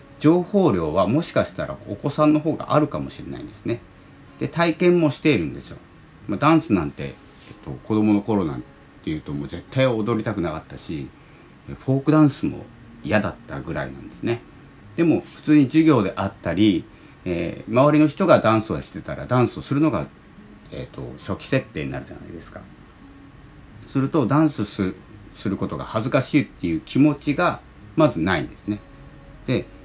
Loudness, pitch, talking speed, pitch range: -22 LUFS, 140 Hz, 360 characters per minute, 105-155 Hz